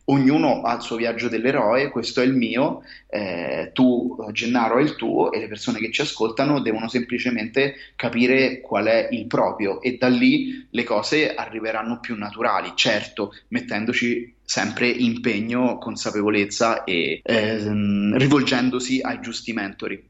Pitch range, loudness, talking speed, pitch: 115-130 Hz, -22 LUFS, 145 wpm, 120 Hz